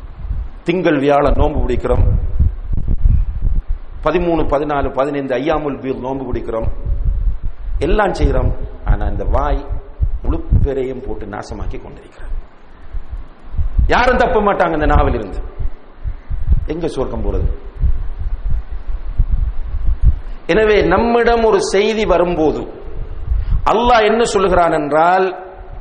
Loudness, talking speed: -17 LUFS, 65 wpm